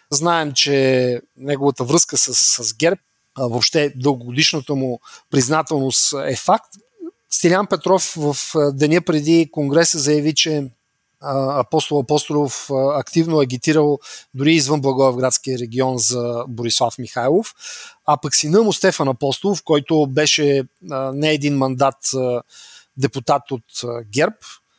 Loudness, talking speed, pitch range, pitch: -17 LUFS, 115 wpm, 130-155 Hz, 145 Hz